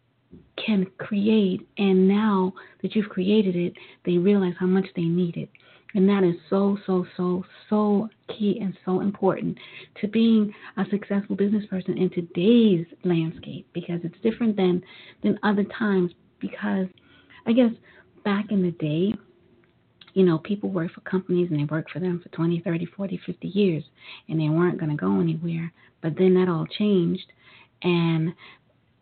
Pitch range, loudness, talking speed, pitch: 170-200 Hz, -24 LUFS, 165 wpm, 185 Hz